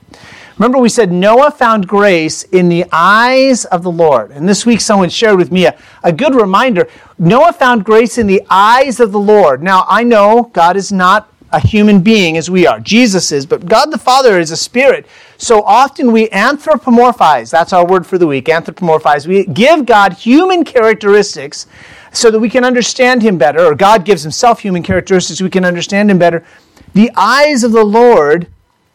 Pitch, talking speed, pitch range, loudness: 210 Hz, 195 wpm, 180-240 Hz, -9 LUFS